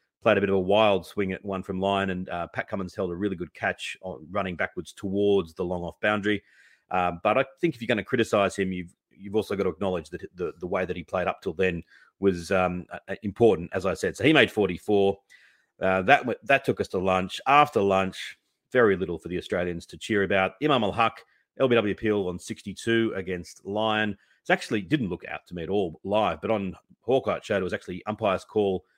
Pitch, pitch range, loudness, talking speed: 100 Hz, 95-110 Hz, -26 LUFS, 220 wpm